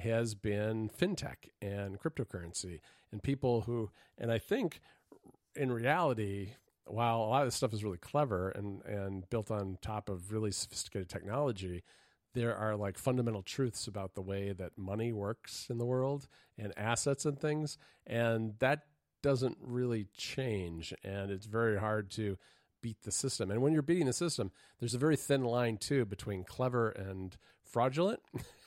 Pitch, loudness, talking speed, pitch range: 110 Hz, -36 LUFS, 165 wpm, 100-125 Hz